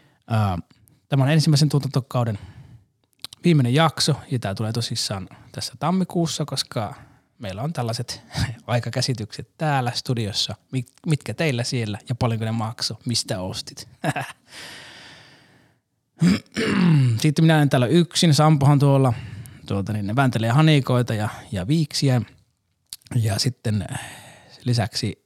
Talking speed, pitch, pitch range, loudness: 105 wpm, 130 Hz, 115-145 Hz, -22 LUFS